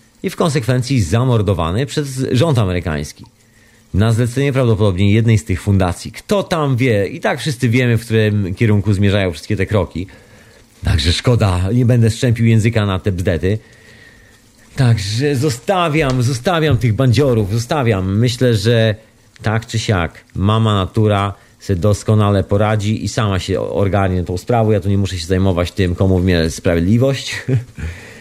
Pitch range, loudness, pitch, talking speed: 100-120 Hz, -16 LUFS, 110 Hz, 145 wpm